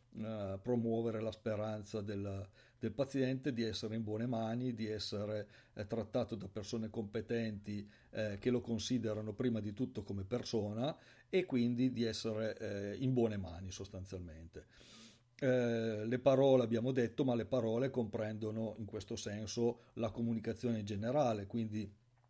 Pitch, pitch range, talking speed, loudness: 115 Hz, 105-120 Hz, 145 wpm, -38 LUFS